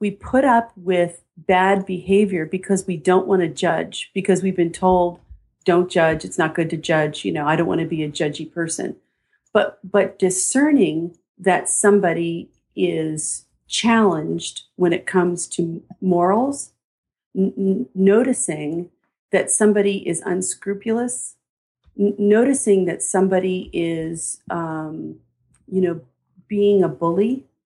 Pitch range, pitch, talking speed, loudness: 170-200 Hz, 185 Hz, 135 wpm, -20 LUFS